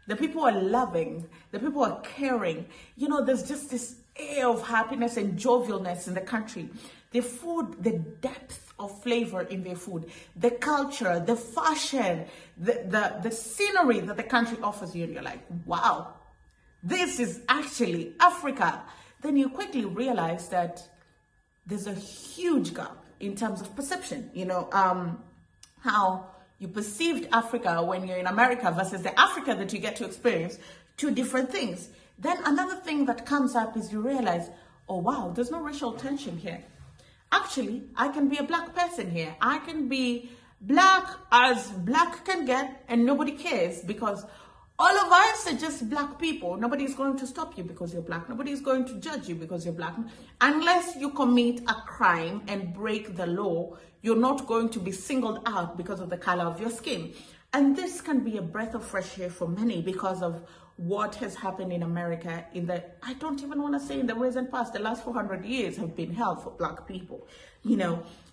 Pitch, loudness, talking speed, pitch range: 235 Hz, -28 LUFS, 185 wpm, 185-270 Hz